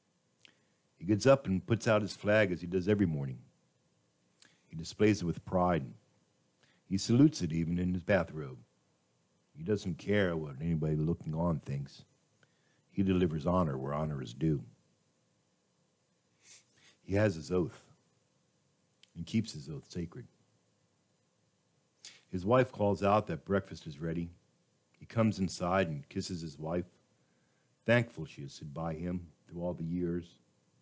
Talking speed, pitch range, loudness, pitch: 145 wpm, 80-105 Hz, -33 LUFS, 90 Hz